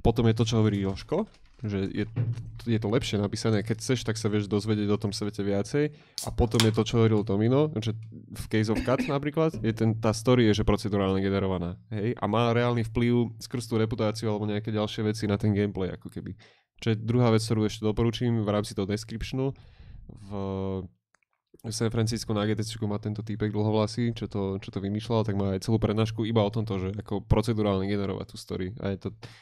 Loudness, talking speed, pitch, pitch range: -28 LUFS, 215 wpm, 110 Hz, 100-115 Hz